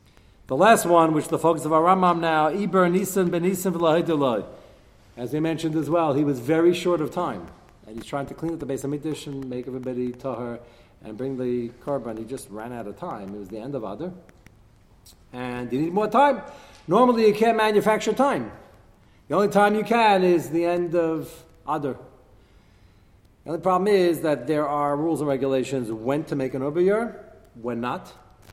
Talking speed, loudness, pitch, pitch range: 195 wpm, -23 LUFS, 150 Hz, 125-175 Hz